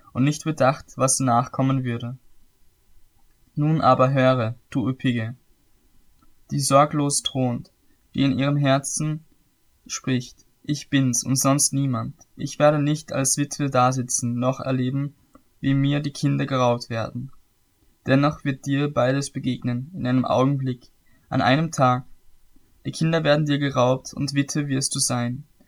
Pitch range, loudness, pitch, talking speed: 125-140 Hz, -22 LUFS, 135 Hz, 140 wpm